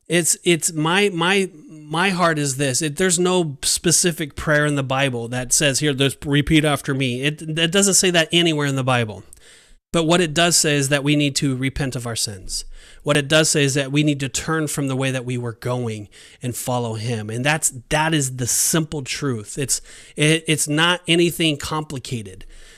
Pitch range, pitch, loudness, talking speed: 130-165 Hz, 150 Hz, -19 LUFS, 210 wpm